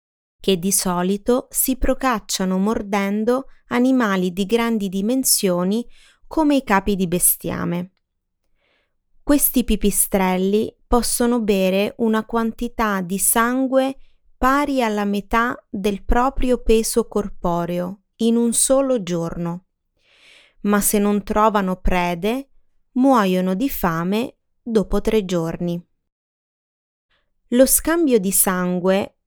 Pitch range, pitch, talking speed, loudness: 190-245 Hz, 215 Hz, 100 wpm, -19 LUFS